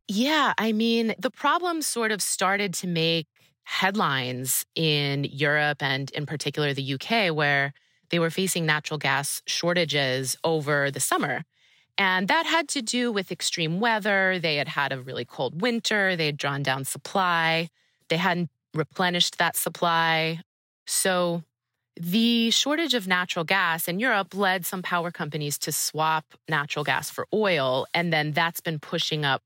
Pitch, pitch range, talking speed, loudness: 165 Hz, 150-195 Hz, 155 wpm, -24 LUFS